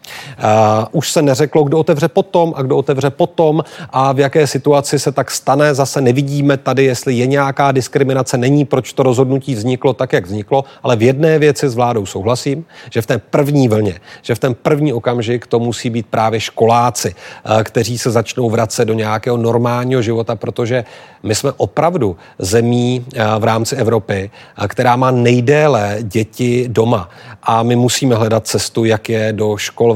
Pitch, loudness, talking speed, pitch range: 125 Hz, -14 LUFS, 170 wpm, 115-140 Hz